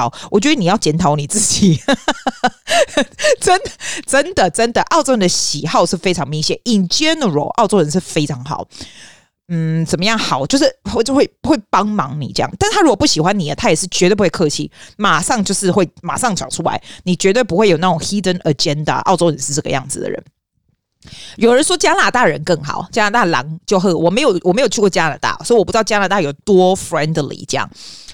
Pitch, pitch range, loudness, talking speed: 190 Hz, 160-235 Hz, -15 LUFS, 355 characters per minute